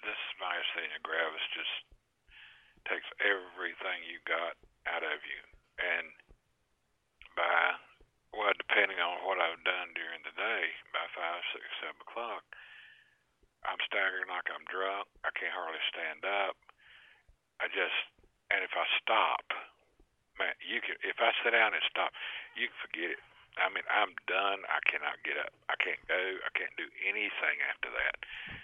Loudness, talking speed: -33 LUFS, 155 wpm